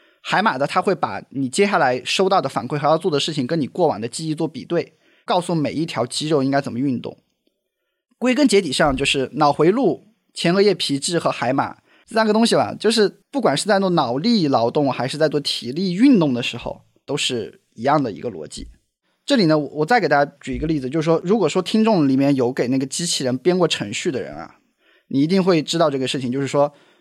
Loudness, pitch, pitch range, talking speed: -19 LUFS, 155 Hz, 140-195 Hz, 330 characters per minute